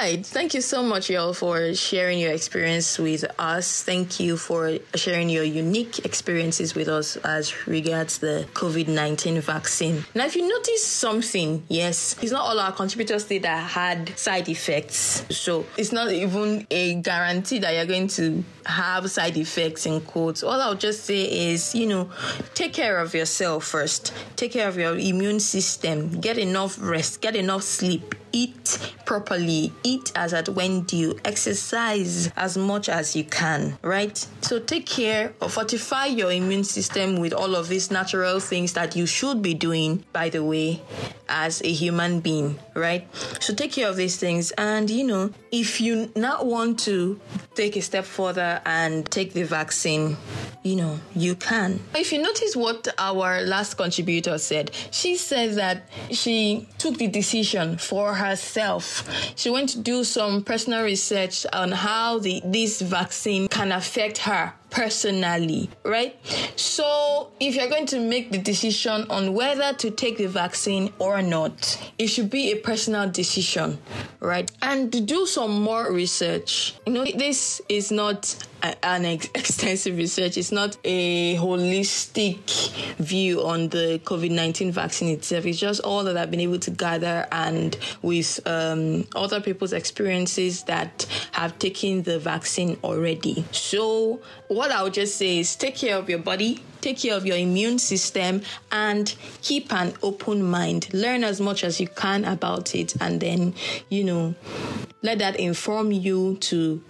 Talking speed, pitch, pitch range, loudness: 165 wpm, 190 Hz, 170-215 Hz, -24 LUFS